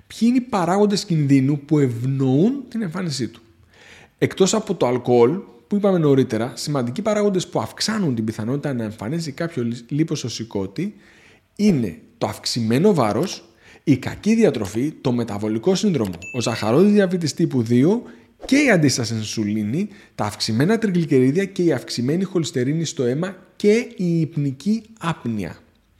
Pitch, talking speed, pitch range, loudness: 150 Hz, 135 wpm, 120-195 Hz, -20 LUFS